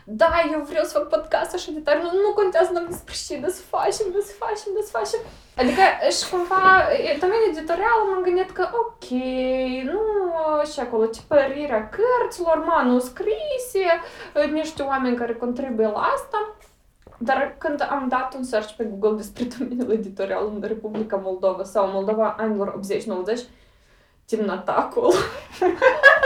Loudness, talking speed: -22 LUFS, 140 wpm